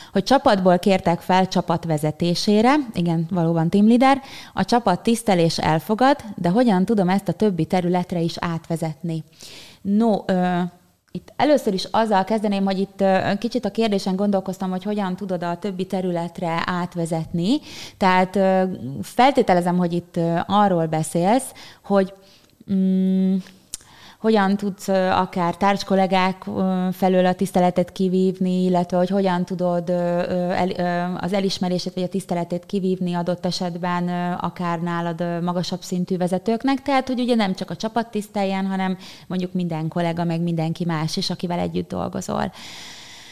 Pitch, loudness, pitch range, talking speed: 185 Hz, -21 LUFS, 175-195 Hz, 135 wpm